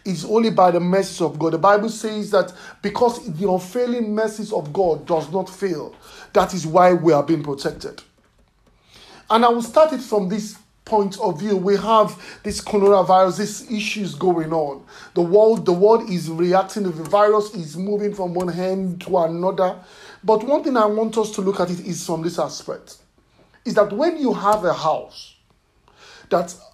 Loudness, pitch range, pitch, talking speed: -19 LUFS, 180-215 Hz, 200 Hz, 185 wpm